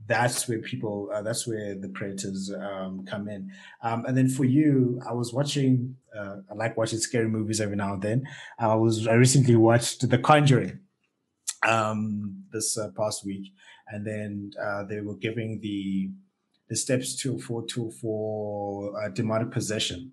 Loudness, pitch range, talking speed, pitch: -26 LUFS, 105-120 Hz, 165 wpm, 110 Hz